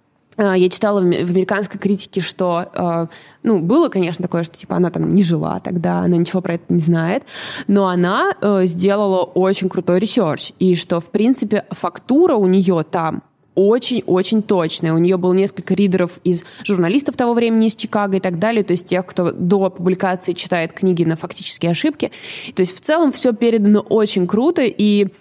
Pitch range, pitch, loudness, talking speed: 180-210 Hz, 190 Hz, -17 LUFS, 175 wpm